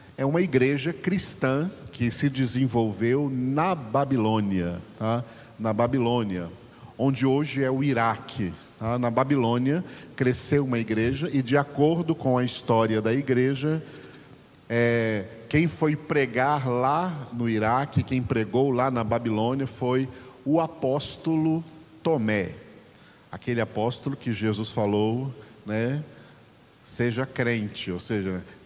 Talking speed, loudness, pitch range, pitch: 120 wpm, -26 LUFS, 115-140 Hz, 125 Hz